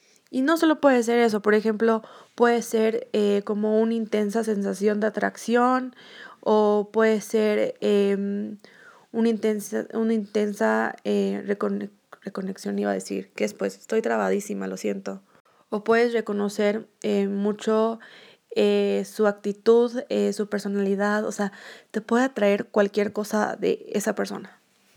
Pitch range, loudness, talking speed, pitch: 200-225 Hz, -24 LUFS, 140 wpm, 210 Hz